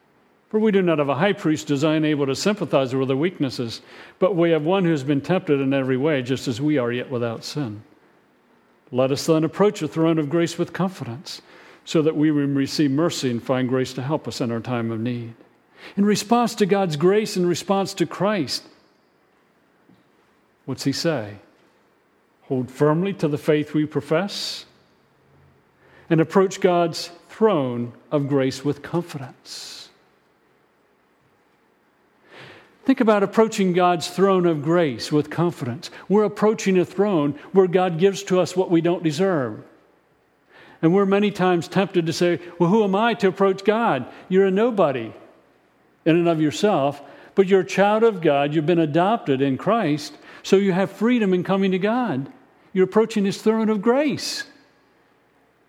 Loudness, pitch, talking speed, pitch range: -21 LUFS, 170 Hz, 165 wpm, 145-195 Hz